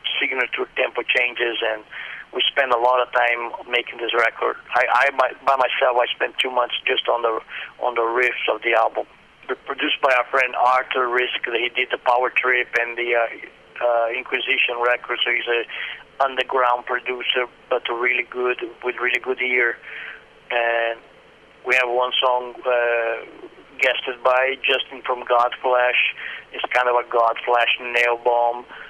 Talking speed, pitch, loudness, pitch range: 160 wpm, 125 Hz, -20 LUFS, 120-125 Hz